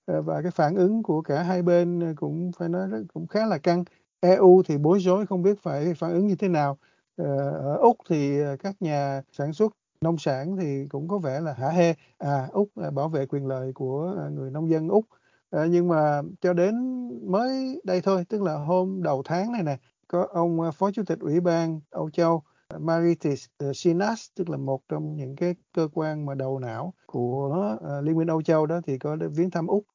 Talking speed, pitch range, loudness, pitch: 205 wpm, 145-185 Hz, -25 LUFS, 165 Hz